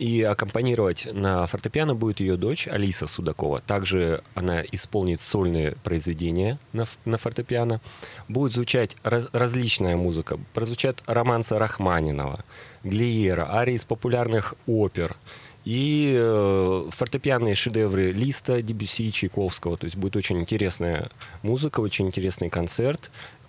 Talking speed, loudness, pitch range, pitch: 110 wpm, -25 LUFS, 95-120 Hz, 110 Hz